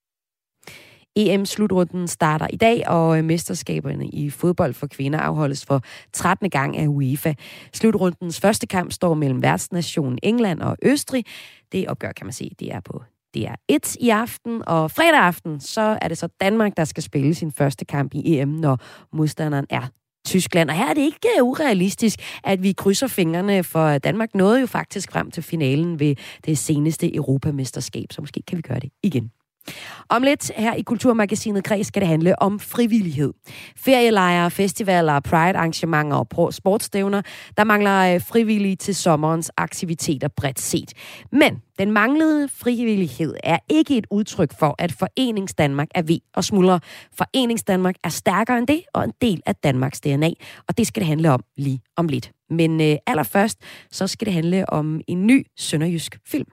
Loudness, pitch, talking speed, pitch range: -20 LUFS, 175 Hz, 170 wpm, 150-210 Hz